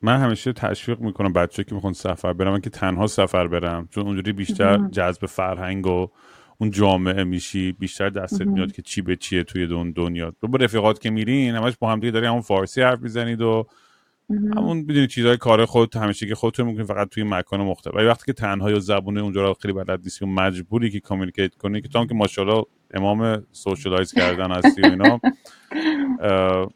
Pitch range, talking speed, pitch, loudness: 95-115 Hz, 185 wpm, 100 Hz, -21 LUFS